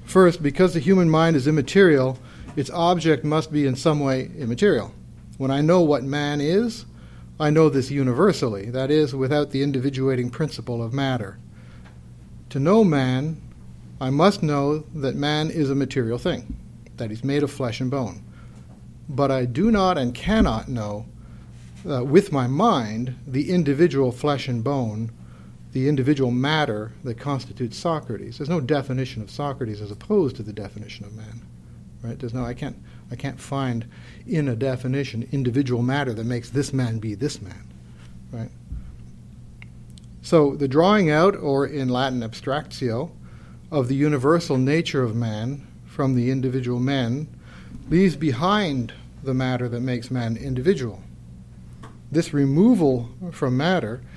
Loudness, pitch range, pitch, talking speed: -22 LUFS, 115-150 Hz, 135 Hz, 150 wpm